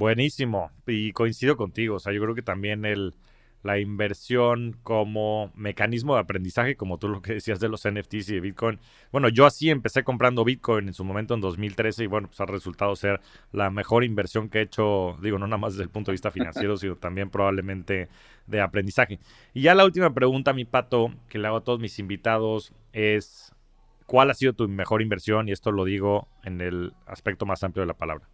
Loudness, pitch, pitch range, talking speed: -25 LUFS, 105 Hz, 100-115 Hz, 210 wpm